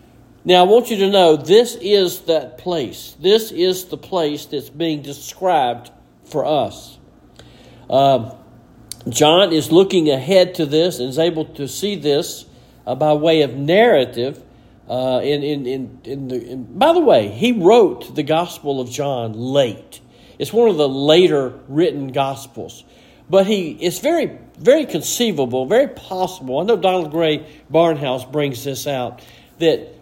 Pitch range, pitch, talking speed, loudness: 130-180 Hz, 150 Hz, 155 wpm, -17 LUFS